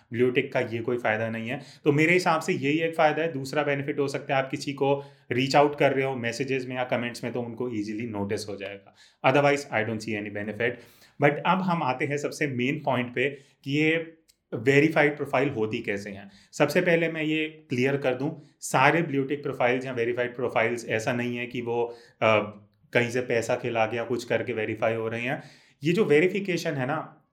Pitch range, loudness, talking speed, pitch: 120-150 Hz, -26 LUFS, 210 wpm, 135 Hz